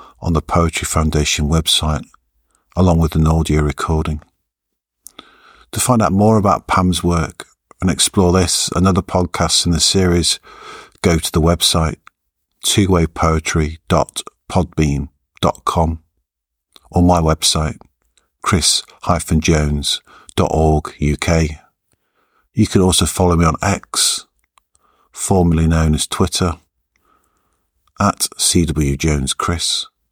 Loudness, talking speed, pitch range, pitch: -16 LUFS, 100 wpm, 80-90 Hz, 80 Hz